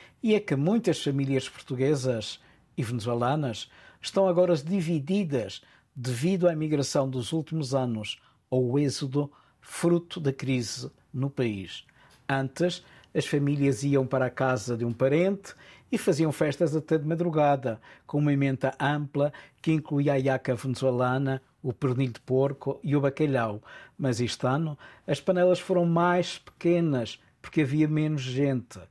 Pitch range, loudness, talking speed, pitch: 130-160 Hz, -27 LUFS, 140 wpm, 140 Hz